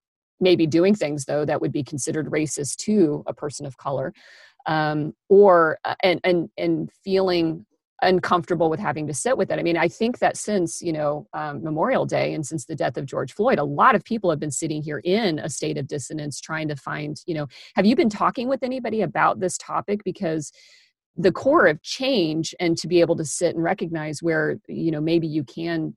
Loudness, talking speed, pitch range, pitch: -22 LUFS, 210 wpm, 150-185 Hz, 165 Hz